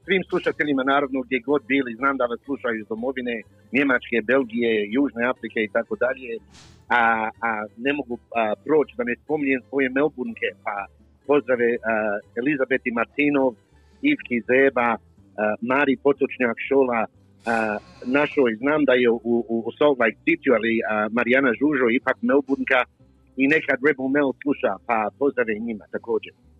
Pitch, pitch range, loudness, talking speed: 125 Hz, 115-140 Hz, -22 LUFS, 140 wpm